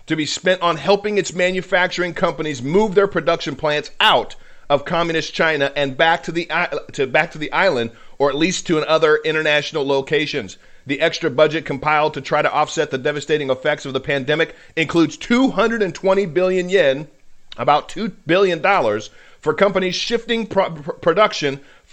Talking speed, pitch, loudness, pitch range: 160 wpm, 160 Hz, -18 LUFS, 150-185 Hz